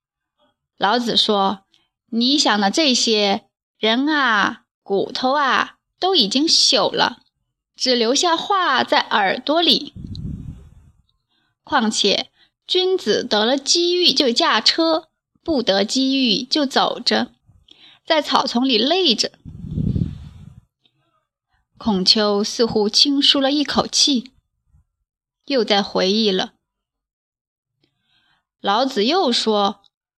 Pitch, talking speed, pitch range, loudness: 250 Hz, 135 characters per minute, 210-295 Hz, -17 LUFS